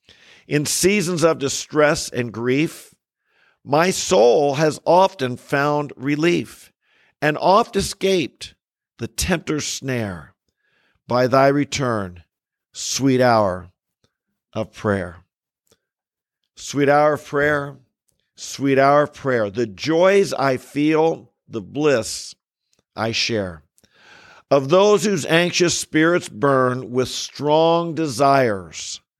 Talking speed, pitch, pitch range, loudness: 105 wpm, 140 Hz, 120-155 Hz, -19 LUFS